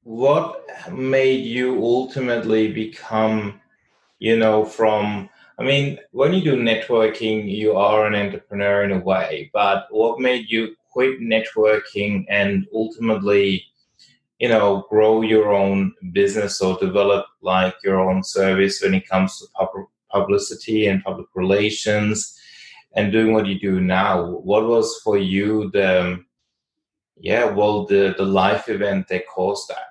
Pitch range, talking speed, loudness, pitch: 95-110 Hz, 140 wpm, -19 LUFS, 105 Hz